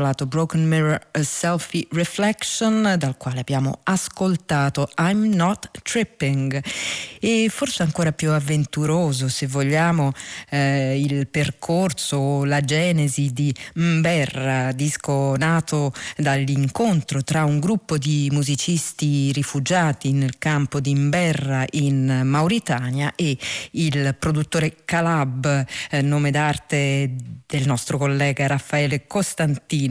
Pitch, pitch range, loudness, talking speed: 145 Hz, 140-165 Hz, -21 LUFS, 110 wpm